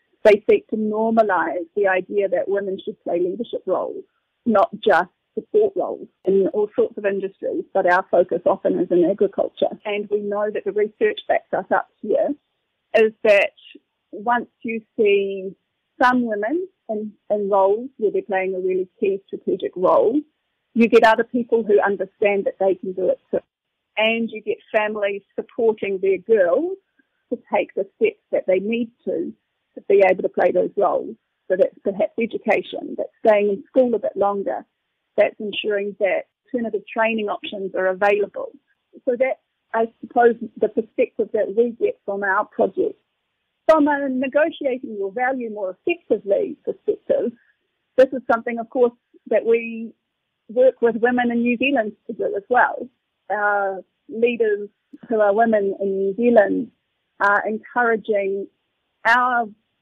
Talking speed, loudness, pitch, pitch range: 155 wpm, -21 LUFS, 225 Hz, 200-285 Hz